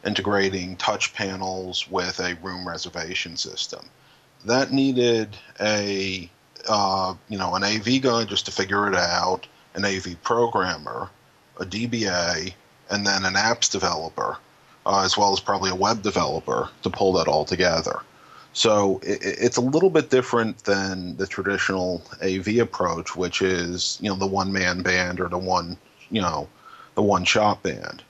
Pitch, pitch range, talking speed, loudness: 100 Hz, 95-110 Hz, 160 wpm, -23 LUFS